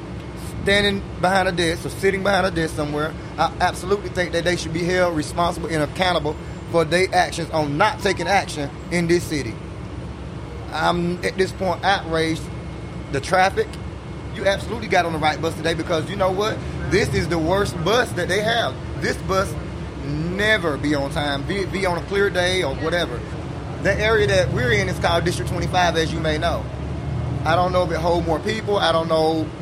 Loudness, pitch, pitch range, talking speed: -21 LUFS, 170 Hz, 160-185 Hz, 195 wpm